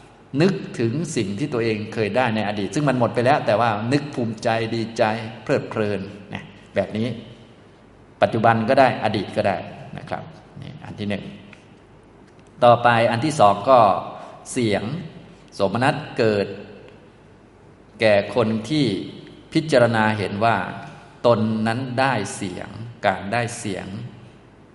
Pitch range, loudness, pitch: 105-125 Hz, -21 LUFS, 115 Hz